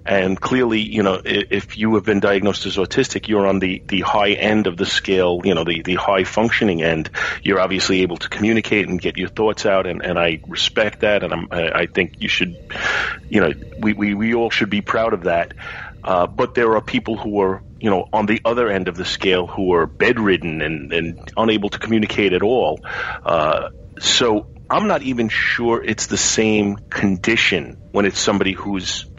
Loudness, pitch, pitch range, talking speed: -18 LUFS, 100 Hz, 95-110 Hz, 205 wpm